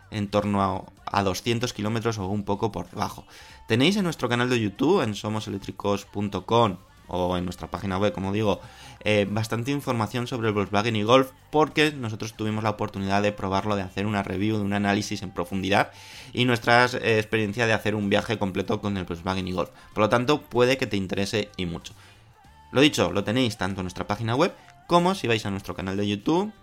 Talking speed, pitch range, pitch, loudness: 205 wpm, 95-115 Hz, 105 Hz, -25 LUFS